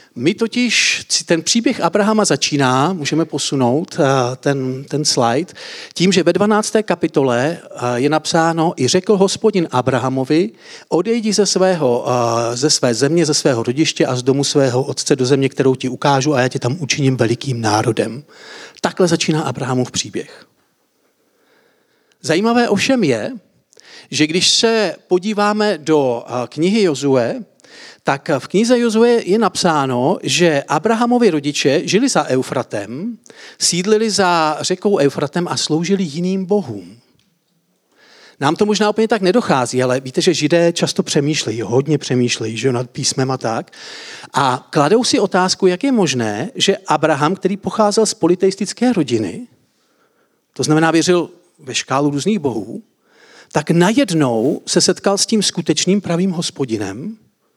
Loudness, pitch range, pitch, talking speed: -16 LUFS, 135-205 Hz, 165 Hz, 135 wpm